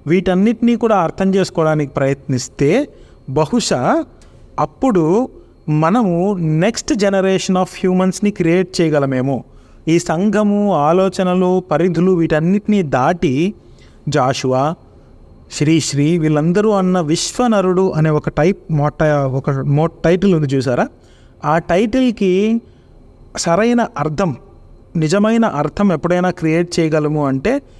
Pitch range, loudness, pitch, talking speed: 150-195 Hz, -15 LUFS, 175 Hz, 95 wpm